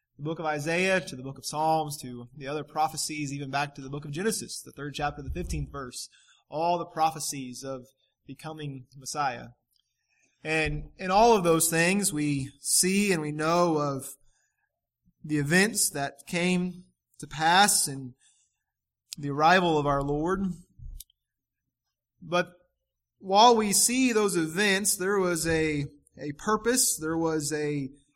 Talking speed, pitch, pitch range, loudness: 145 wpm, 155 Hz, 140-180 Hz, -26 LUFS